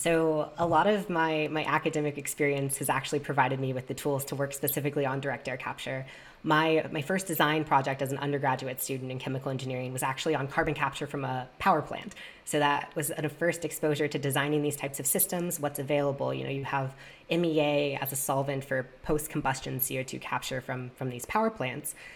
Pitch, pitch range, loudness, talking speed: 145 Hz, 135-155 Hz, -30 LUFS, 205 wpm